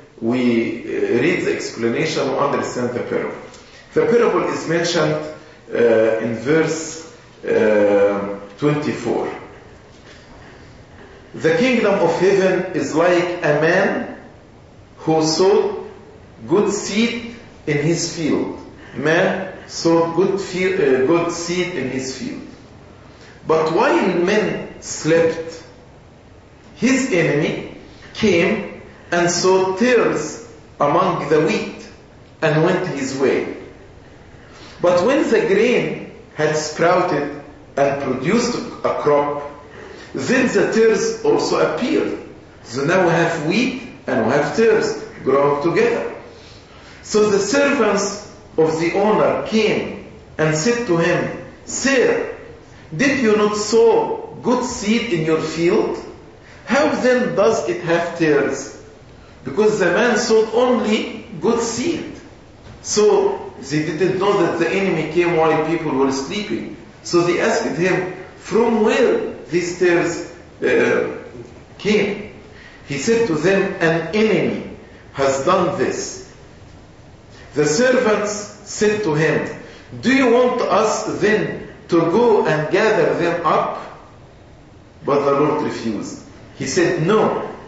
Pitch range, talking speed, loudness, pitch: 155-235 Hz, 120 wpm, -18 LUFS, 180 Hz